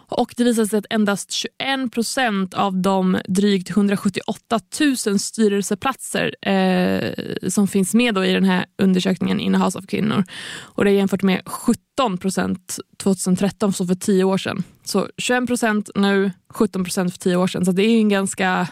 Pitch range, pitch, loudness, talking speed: 185-215 Hz, 195 Hz, -20 LUFS, 175 wpm